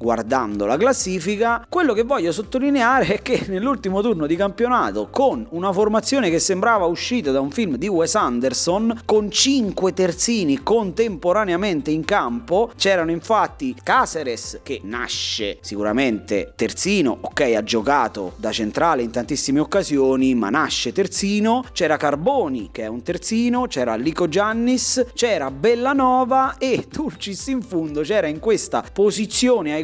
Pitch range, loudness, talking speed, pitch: 155-235 Hz, -19 LUFS, 140 wpm, 200 Hz